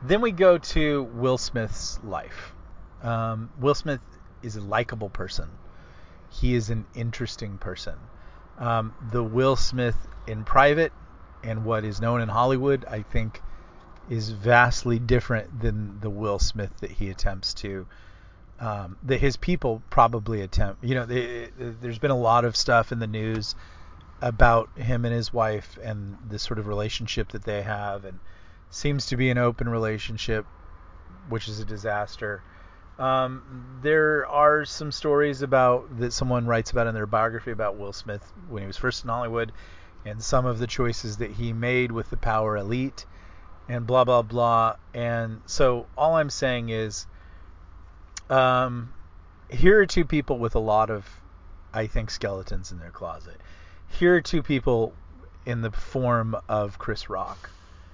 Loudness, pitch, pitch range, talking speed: -25 LUFS, 115 Hz, 95-125 Hz, 160 wpm